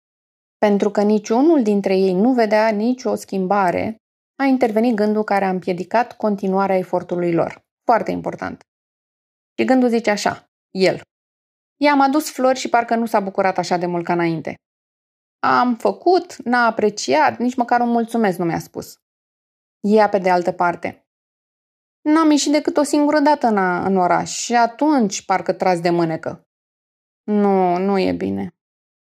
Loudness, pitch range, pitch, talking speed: -18 LUFS, 185-245 Hz, 210 Hz, 150 wpm